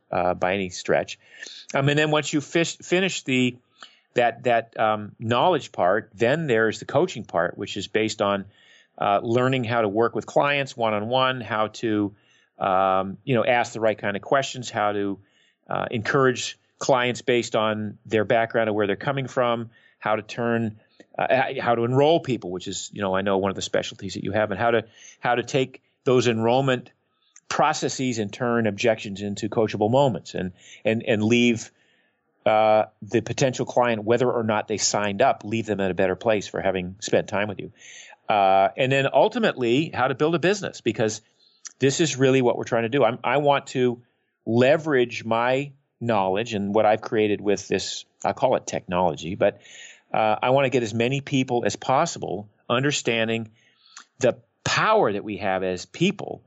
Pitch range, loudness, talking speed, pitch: 105-130 Hz, -23 LUFS, 190 wpm, 115 Hz